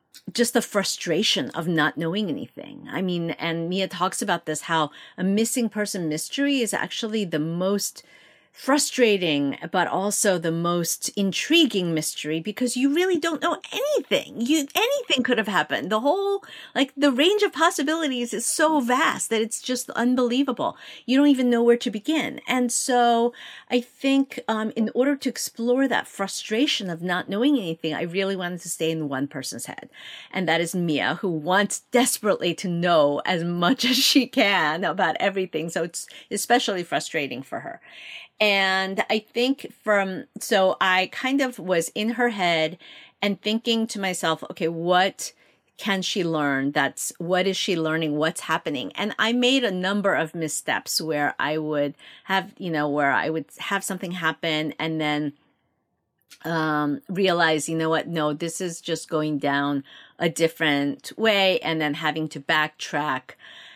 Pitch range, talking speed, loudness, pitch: 165-245 Hz, 165 wpm, -23 LUFS, 195 Hz